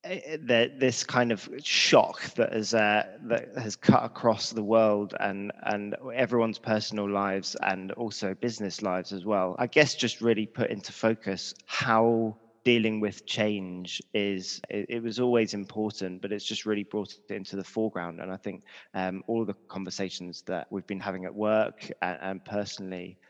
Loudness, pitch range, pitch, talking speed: -28 LUFS, 95-115 Hz, 105 Hz, 175 wpm